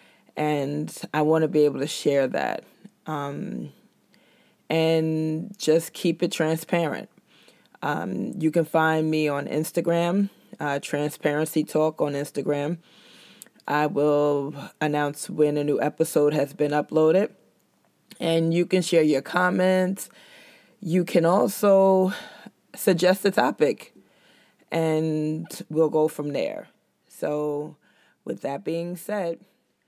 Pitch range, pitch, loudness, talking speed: 150-175 Hz, 160 Hz, -24 LUFS, 120 wpm